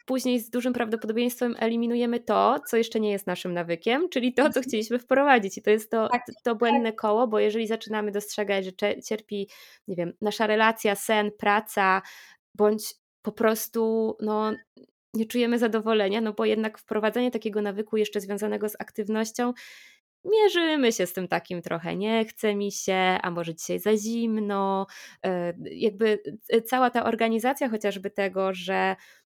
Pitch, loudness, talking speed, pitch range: 220 Hz, -26 LUFS, 155 wpm, 205-235 Hz